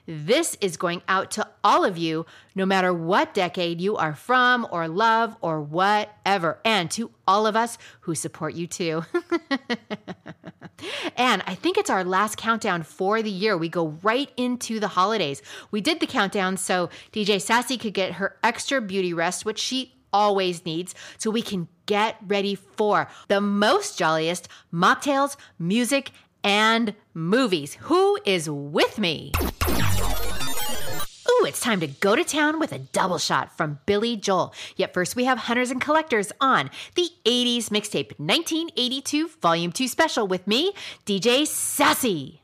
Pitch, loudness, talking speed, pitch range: 205 Hz, -23 LUFS, 155 wpm, 175-245 Hz